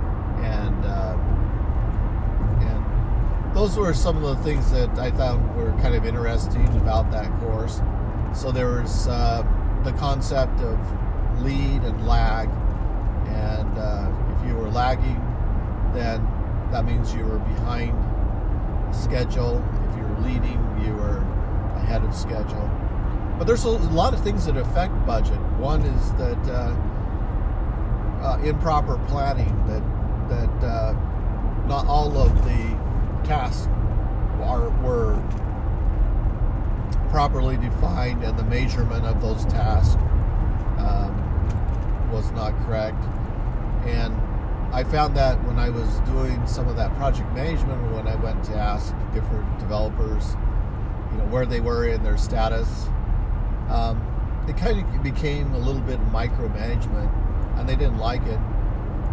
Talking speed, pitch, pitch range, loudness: 135 wpm, 110 Hz, 100-110 Hz, -24 LUFS